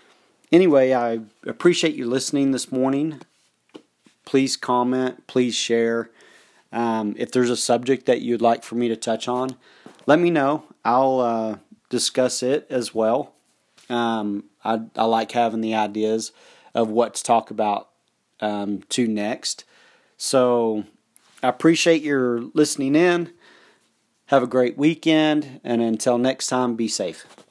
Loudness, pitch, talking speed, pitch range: -21 LUFS, 125 Hz, 140 wpm, 115-135 Hz